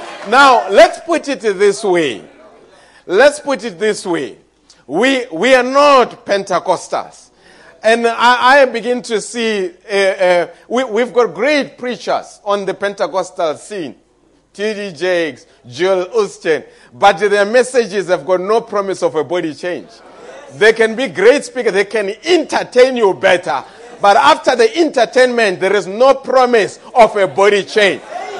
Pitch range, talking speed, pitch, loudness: 190-255 Hz, 150 wpm, 220 Hz, -13 LUFS